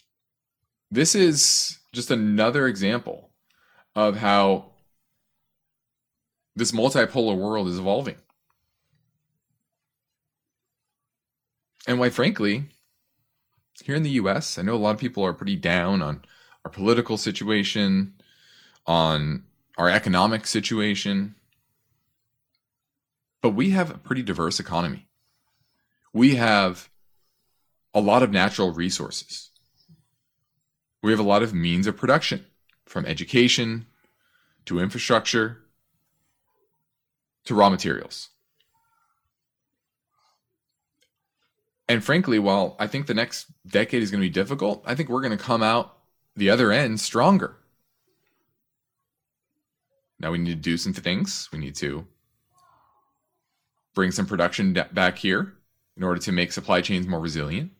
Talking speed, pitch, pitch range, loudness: 115 wpm, 115 Hz, 100-145 Hz, -23 LUFS